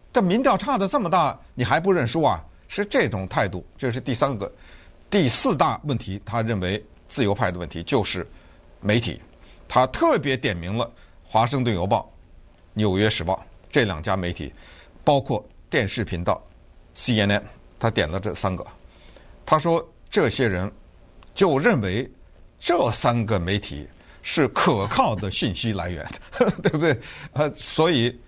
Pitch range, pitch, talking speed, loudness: 85-125 Hz, 105 Hz, 225 characters per minute, -23 LUFS